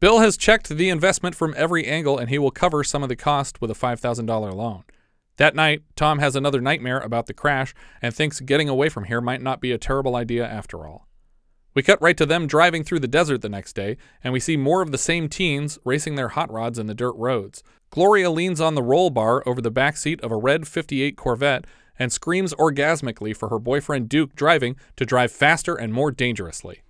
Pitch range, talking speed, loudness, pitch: 120-160 Hz, 225 wpm, -21 LUFS, 140 Hz